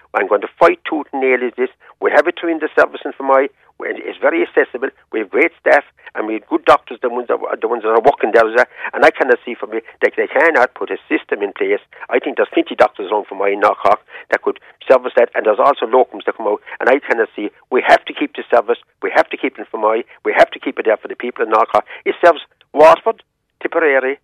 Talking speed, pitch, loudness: 260 wpm, 370 Hz, -15 LUFS